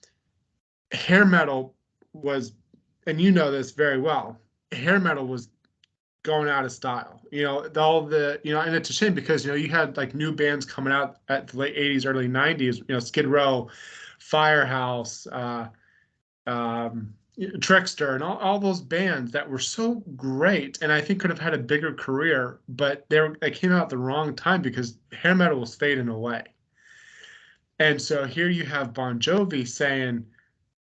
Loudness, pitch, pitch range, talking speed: -24 LUFS, 145 Hz, 130-165 Hz, 180 wpm